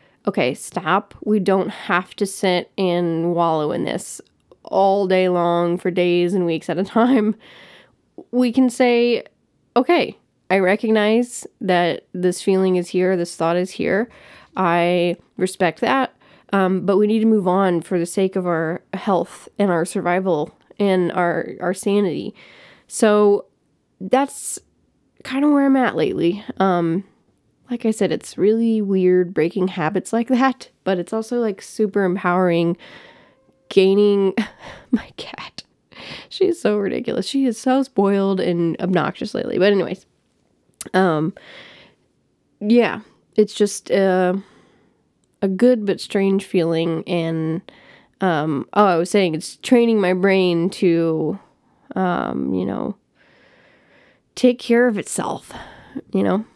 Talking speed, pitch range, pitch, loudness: 135 wpm, 175-215 Hz, 195 Hz, -19 LUFS